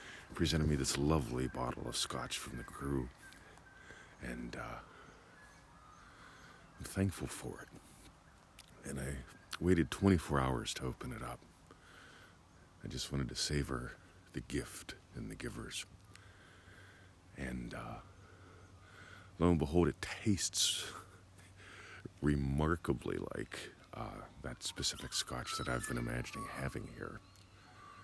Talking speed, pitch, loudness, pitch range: 115 wpm, 80 Hz, -38 LUFS, 70-95 Hz